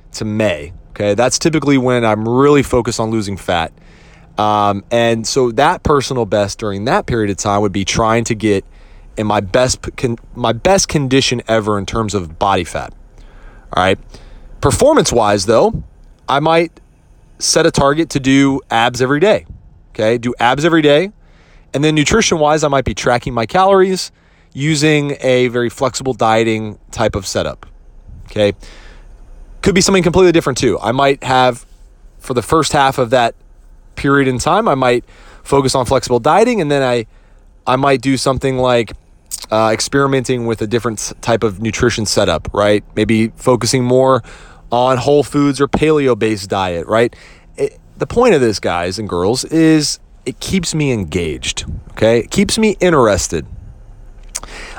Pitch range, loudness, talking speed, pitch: 105-140 Hz, -14 LUFS, 165 wpm, 125 Hz